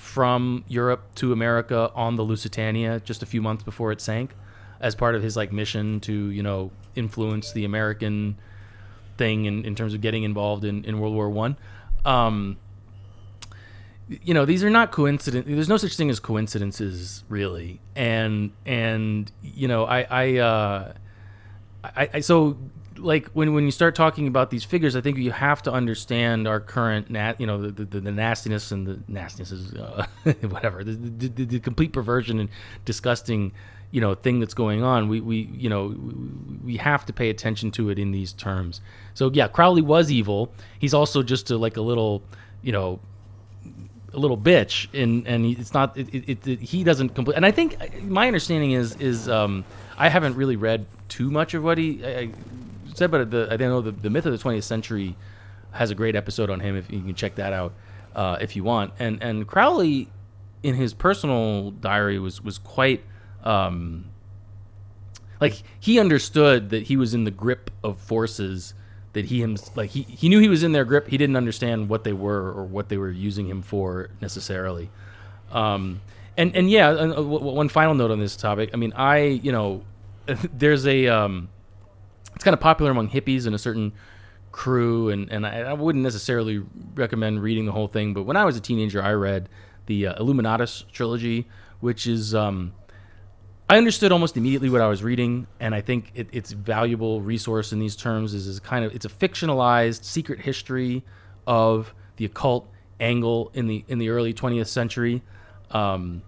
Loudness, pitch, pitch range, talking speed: -23 LUFS, 110 Hz, 100-125 Hz, 190 wpm